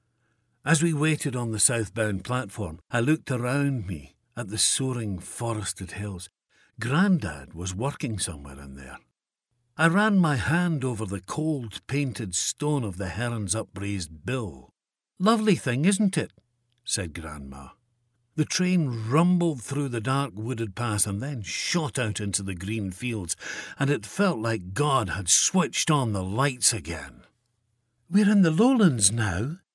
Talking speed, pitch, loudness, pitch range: 150 wpm, 120 Hz, -26 LUFS, 100-145 Hz